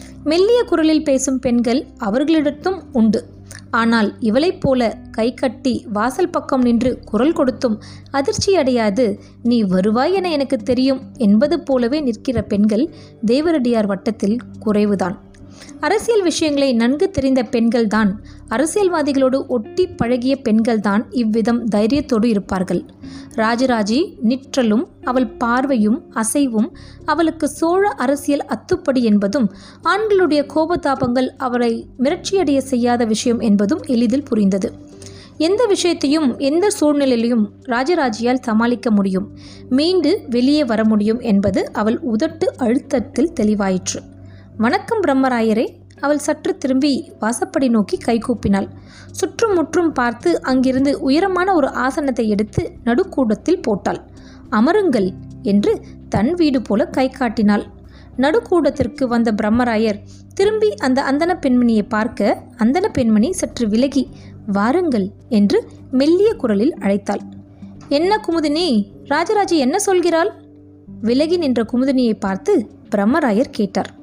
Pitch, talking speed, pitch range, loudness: 255 Hz, 105 wpm, 220-300 Hz, -17 LUFS